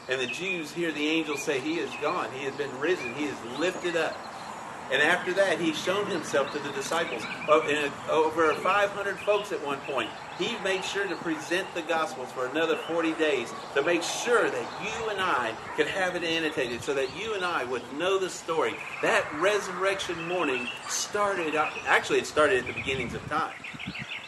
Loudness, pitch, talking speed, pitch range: -28 LUFS, 180 Hz, 190 wpm, 160-200 Hz